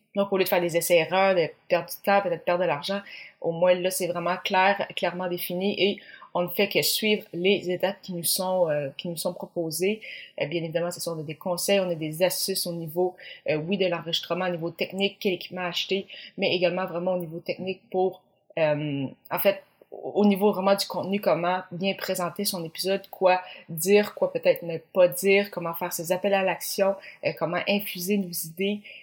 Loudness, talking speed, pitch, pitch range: -26 LUFS, 205 wpm, 185 Hz, 175-195 Hz